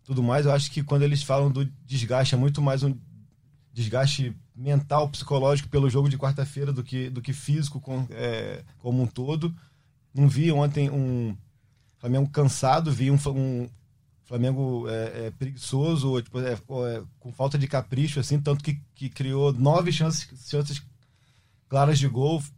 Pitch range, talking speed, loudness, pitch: 125-140 Hz, 165 wpm, -25 LUFS, 135 Hz